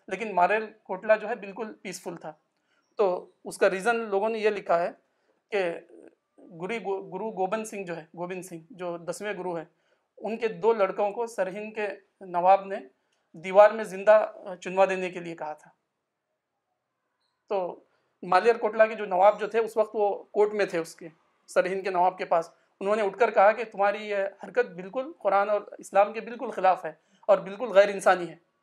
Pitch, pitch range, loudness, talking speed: 195 Hz, 185-215 Hz, -26 LUFS, 190 wpm